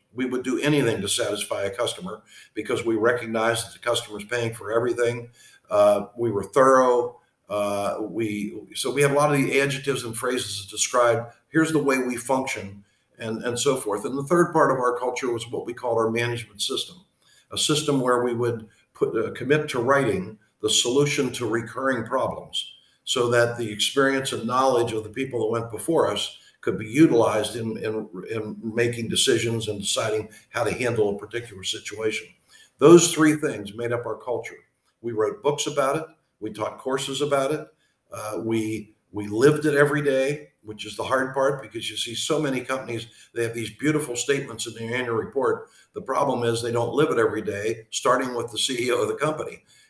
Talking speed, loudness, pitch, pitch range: 195 wpm, -23 LUFS, 120 Hz, 110-135 Hz